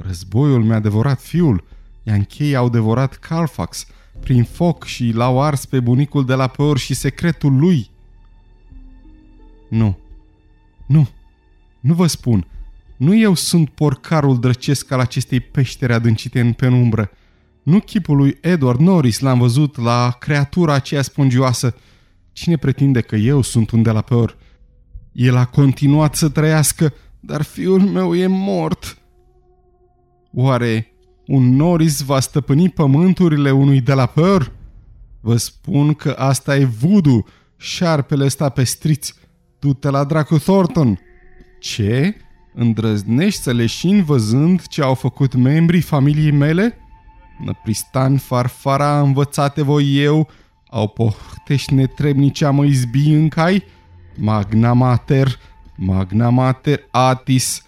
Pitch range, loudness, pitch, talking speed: 115-150 Hz, -16 LUFS, 130 Hz, 125 wpm